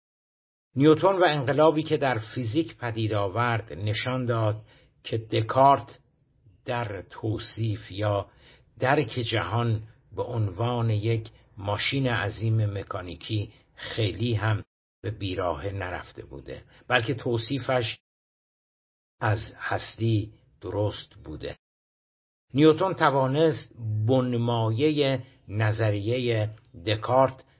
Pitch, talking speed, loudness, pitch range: 115 Hz, 85 wpm, -26 LUFS, 105-130 Hz